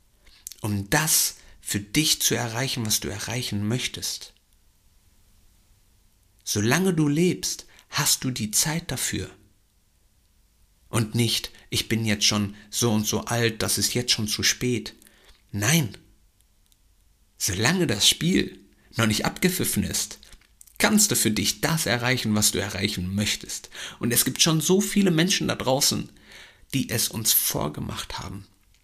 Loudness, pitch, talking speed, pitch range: -23 LUFS, 105 Hz, 135 wpm, 100-120 Hz